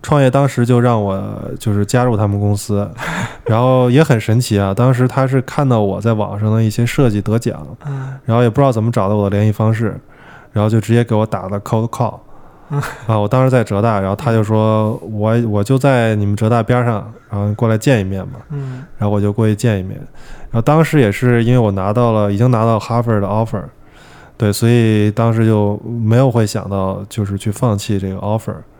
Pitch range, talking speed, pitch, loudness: 105-125 Hz, 330 characters per minute, 115 Hz, -15 LUFS